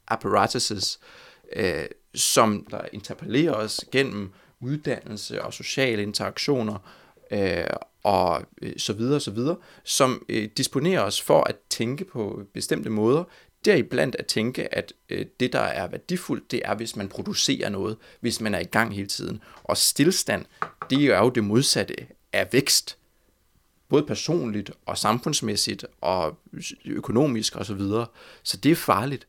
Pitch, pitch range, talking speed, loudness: 115 Hz, 105-145 Hz, 155 wpm, -25 LUFS